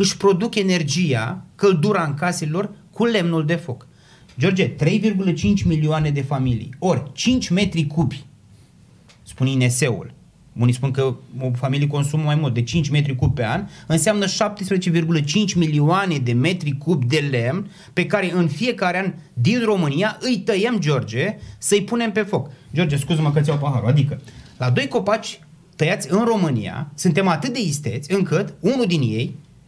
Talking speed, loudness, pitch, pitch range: 160 wpm, -20 LUFS, 160 Hz, 140-195 Hz